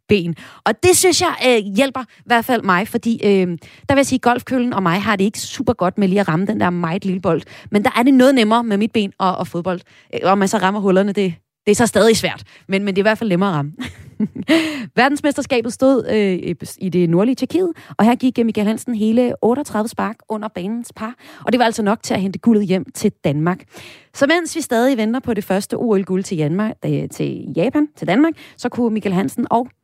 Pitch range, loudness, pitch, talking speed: 190-245 Hz, -17 LUFS, 220 Hz, 230 wpm